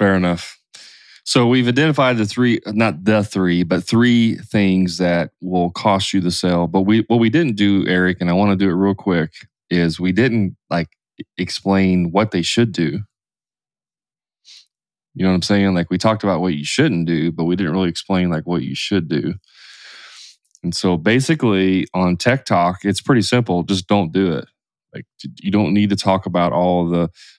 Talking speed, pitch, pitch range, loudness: 195 wpm, 95 Hz, 90-105 Hz, -17 LUFS